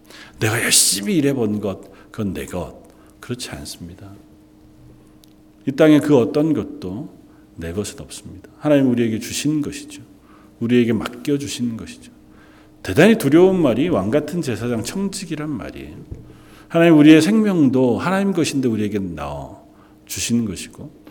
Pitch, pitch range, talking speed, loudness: 120 Hz, 100-150 Hz, 305 characters per minute, -18 LUFS